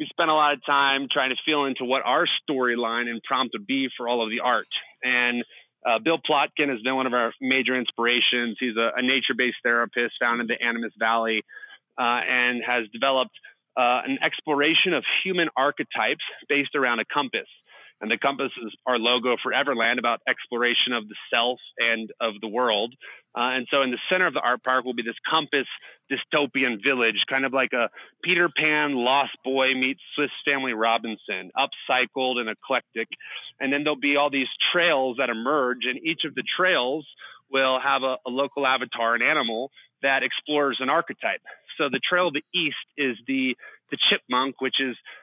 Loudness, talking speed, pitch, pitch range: -23 LUFS, 190 wpm, 130 Hz, 120-140 Hz